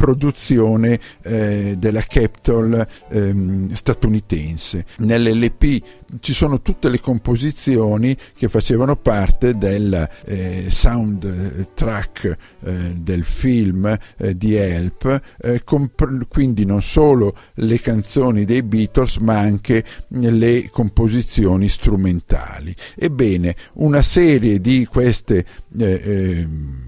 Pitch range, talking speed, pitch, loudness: 95-120 Hz, 105 wpm, 110 Hz, -18 LUFS